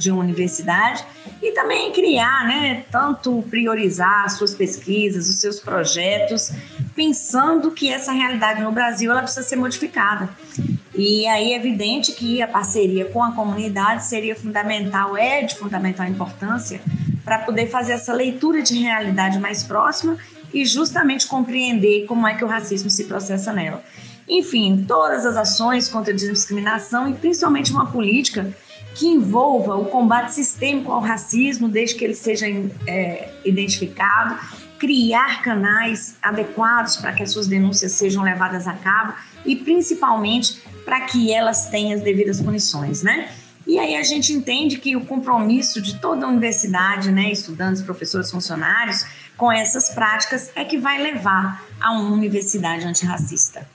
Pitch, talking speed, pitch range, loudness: 220 Hz, 150 wpm, 195-255 Hz, -19 LUFS